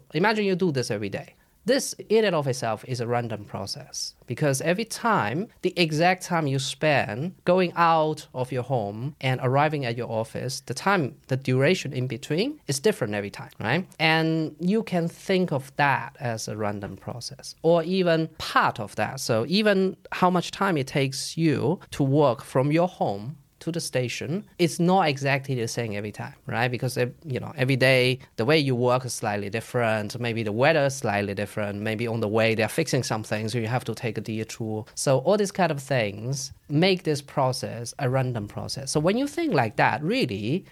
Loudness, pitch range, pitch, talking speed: -25 LUFS, 115-165 Hz, 135 Hz, 200 wpm